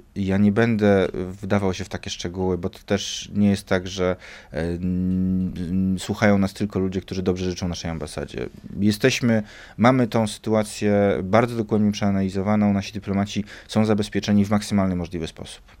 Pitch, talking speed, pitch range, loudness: 100 Hz, 150 wpm, 95-105 Hz, -22 LUFS